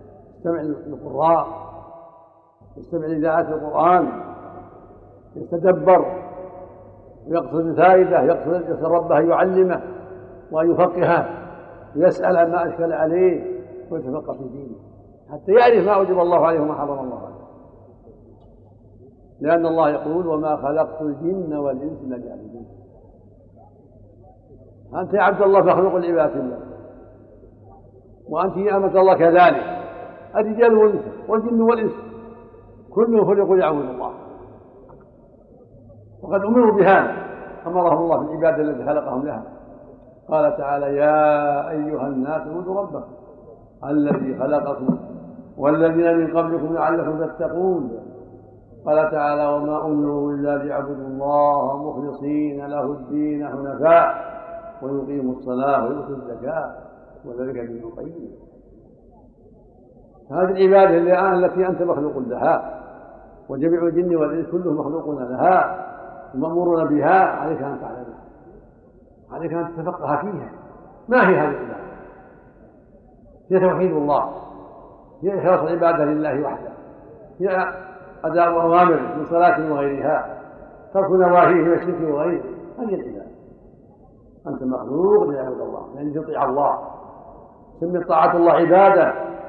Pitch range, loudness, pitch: 140-175 Hz, -19 LUFS, 160 Hz